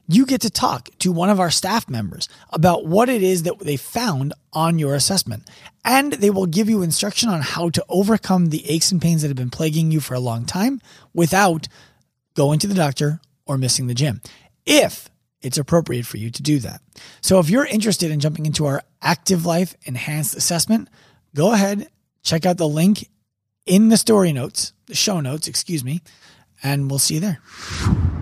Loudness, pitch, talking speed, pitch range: -19 LUFS, 165 Hz, 195 wpm, 140-190 Hz